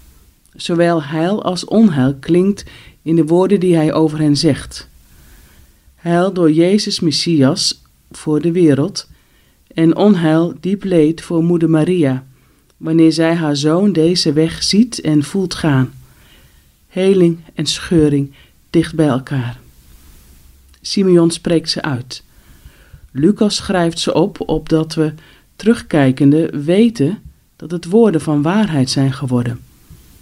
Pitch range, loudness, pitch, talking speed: 130-175 Hz, -14 LUFS, 155 Hz, 125 wpm